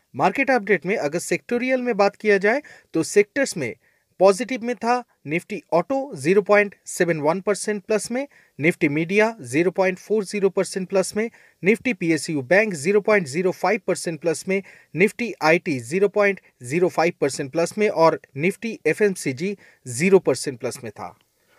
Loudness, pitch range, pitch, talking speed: -21 LUFS, 165-210 Hz, 195 Hz, 135 wpm